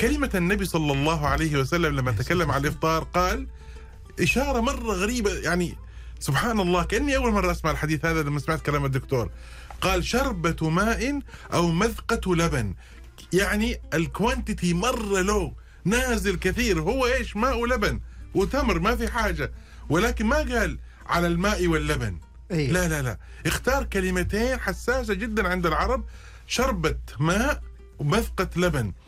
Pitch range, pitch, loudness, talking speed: 145-220 Hz, 175 Hz, -25 LUFS, 135 wpm